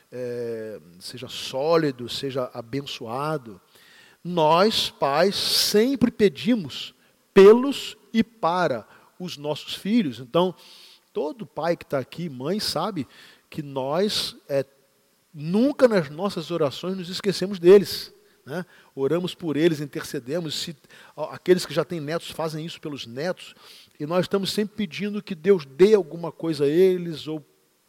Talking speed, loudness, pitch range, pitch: 130 wpm, -23 LUFS, 140-190 Hz, 165 Hz